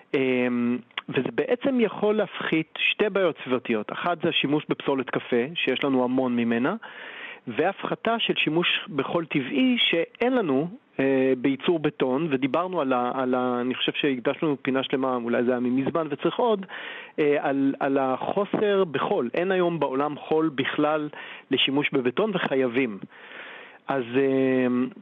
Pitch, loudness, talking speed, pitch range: 140 Hz, -25 LUFS, 135 wpm, 130-170 Hz